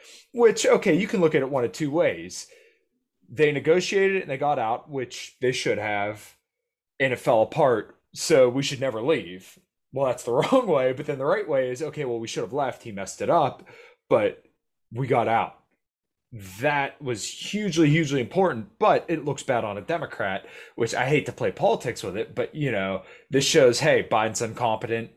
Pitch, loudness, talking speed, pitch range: 145 Hz, -24 LUFS, 200 wpm, 120-195 Hz